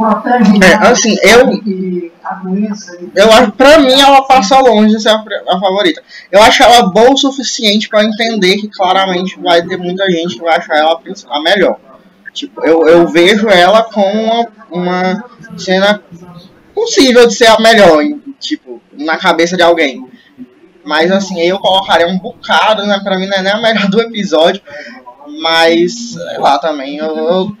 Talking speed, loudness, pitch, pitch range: 165 wpm, -9 LUFS, 195 Hz, 175-230 Hz